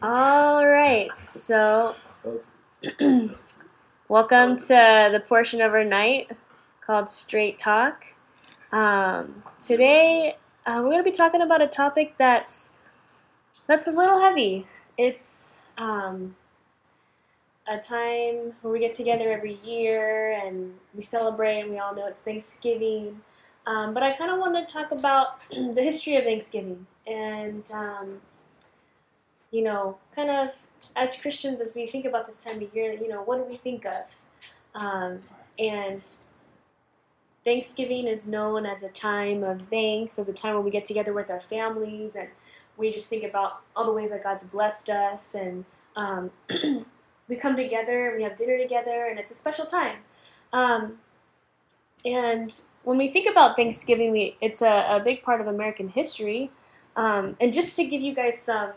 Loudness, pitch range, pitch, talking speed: -24 LUFS, 210-255 Hz, 225 Hz, 155 wpm